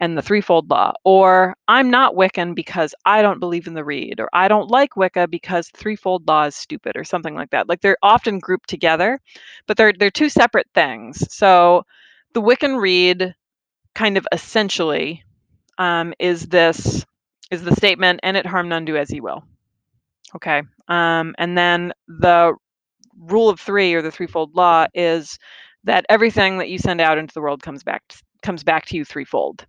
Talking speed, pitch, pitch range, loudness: 185 wpm, 180 Hz, 165-195 Hz, -17 LUFS